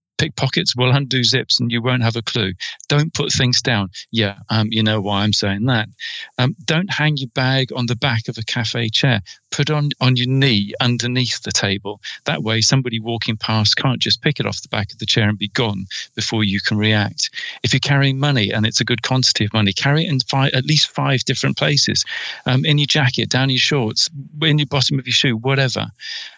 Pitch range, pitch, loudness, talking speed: 110-135 Hz, 125 Hz, -17 LUFS, 225 wpm